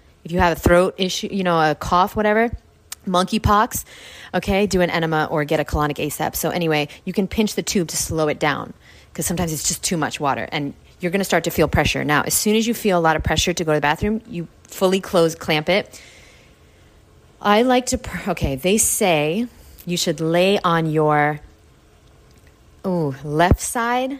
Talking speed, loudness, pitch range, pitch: 205 wpm, -19 LUFS, 155-195 Hz, 175 Hz